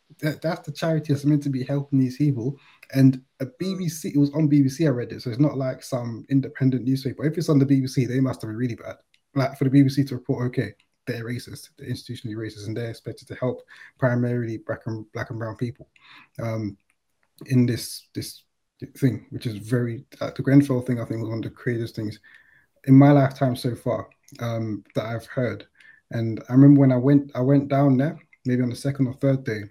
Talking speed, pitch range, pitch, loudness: 220 wpm, 115-140 Hz, 130 Hz, -23 LUFS